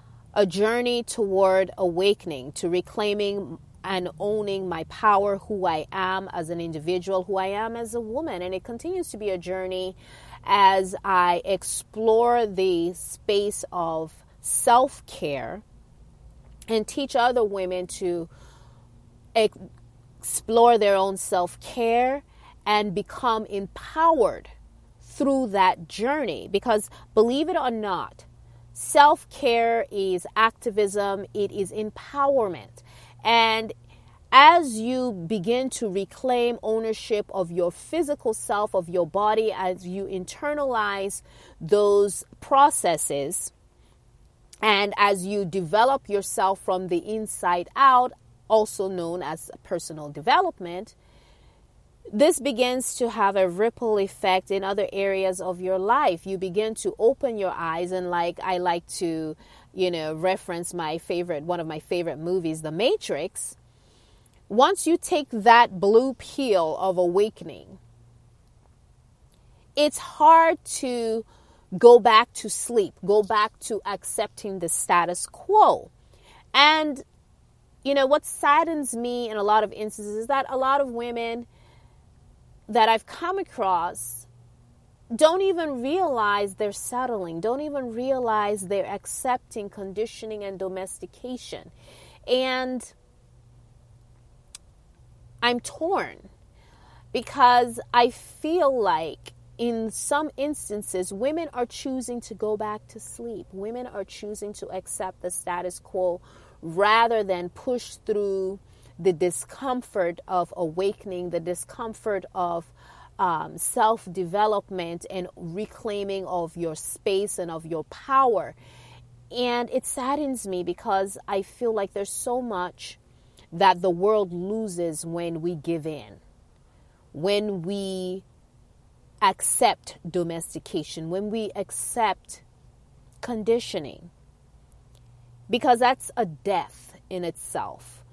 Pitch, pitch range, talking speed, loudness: 200 Hz, 180-235 Hz, 120 wpm, -24 LUFS